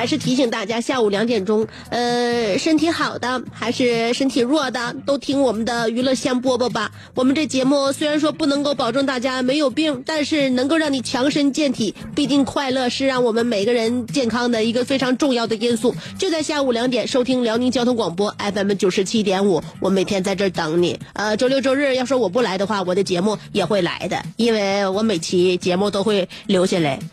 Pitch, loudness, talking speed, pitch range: 245 Hz, -19 LUFS, 320 characters per minute, 210-270 Hz